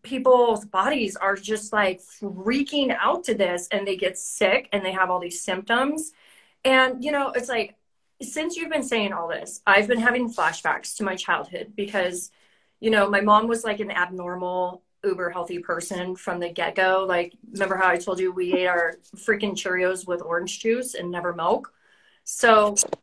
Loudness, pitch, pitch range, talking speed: -23 LUFS, 200 Hz, 180-230 Hz, 185 wpm